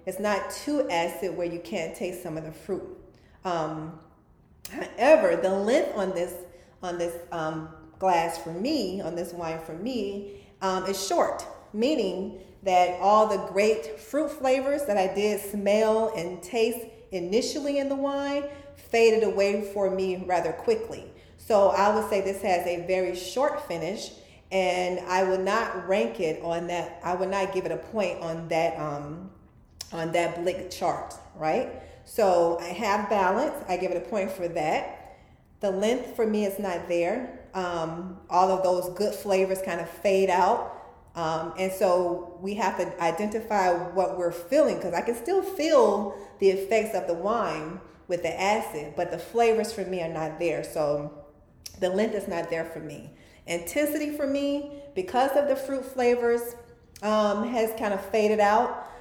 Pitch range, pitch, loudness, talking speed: 175-220 Hz, 190 Hz, -27 LUFS, 170 wpm